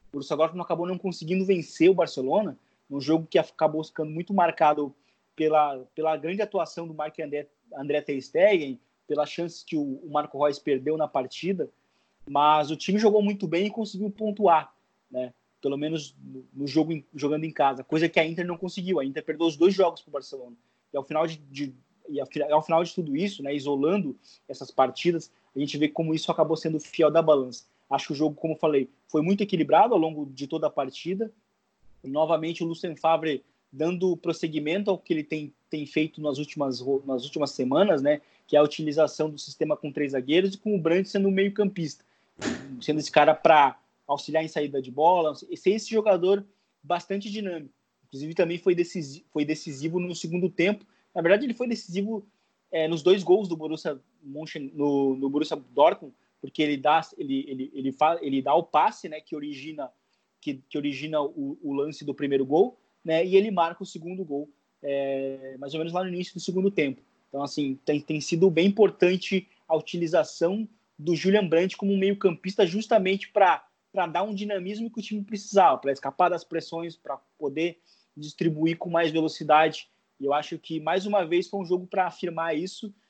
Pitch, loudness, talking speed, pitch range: 160 Hz, -26 LUFS, 195 wpm, 145-185 Hz